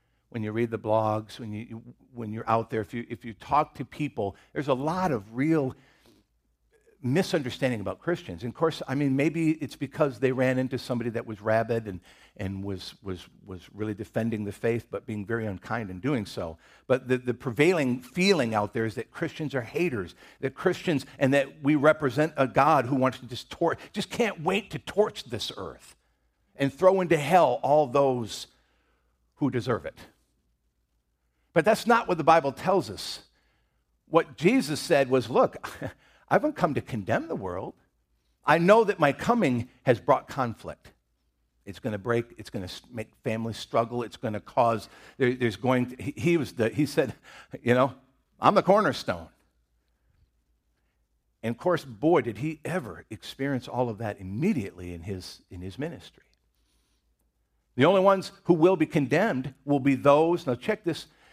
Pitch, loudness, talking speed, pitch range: 120 Hz, -27 LUFS, 180 wpm, 100-145 Hz